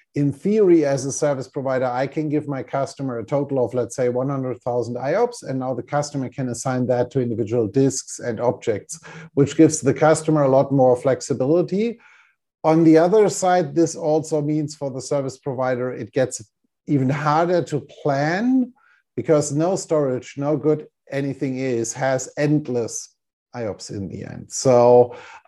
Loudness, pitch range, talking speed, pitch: -21 LUFS, 125-155 Hz, 165 wpm, 140 Hz